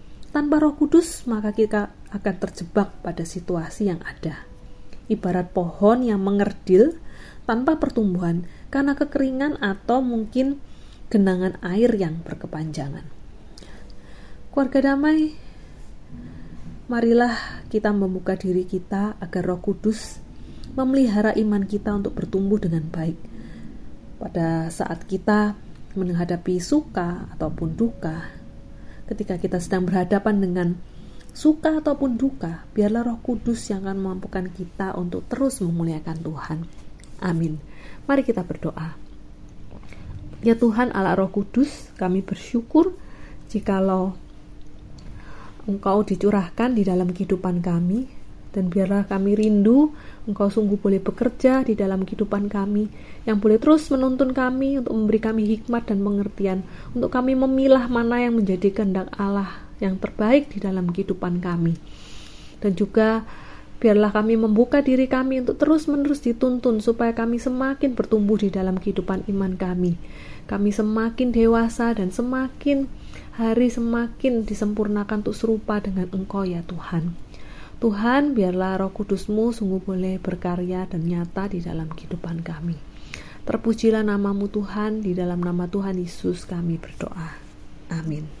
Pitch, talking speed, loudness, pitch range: 200 Hz, 120 wpm, -23 LUFS, 180-235 Hz